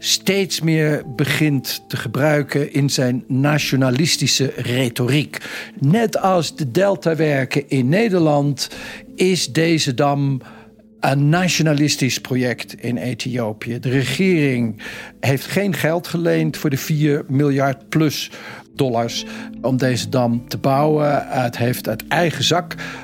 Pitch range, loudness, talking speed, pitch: 130-160 Hz, -18 LUFS, 115 wpm, 145 Hz